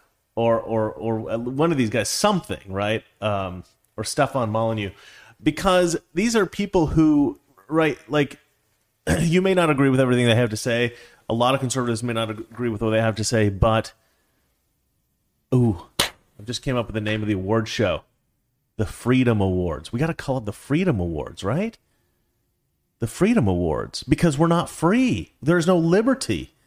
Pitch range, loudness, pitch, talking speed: 110-155 Hz, -22 LUFS, 120 Hz, 180 wpm